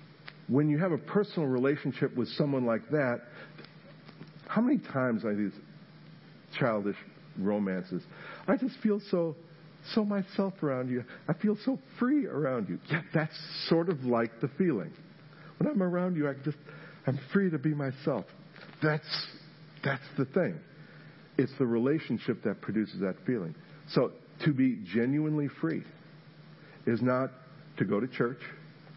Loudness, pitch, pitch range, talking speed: -31 LUFS, 155 Hz, 135-165 Hz, 145 wpm